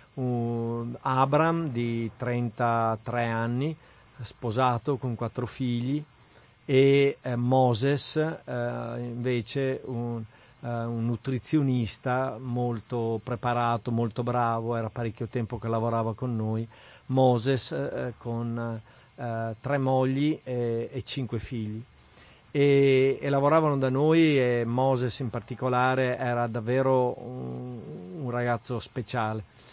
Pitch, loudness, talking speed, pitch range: 120 Hz, -27 LUFS, 105 wpm, 115-130 Hz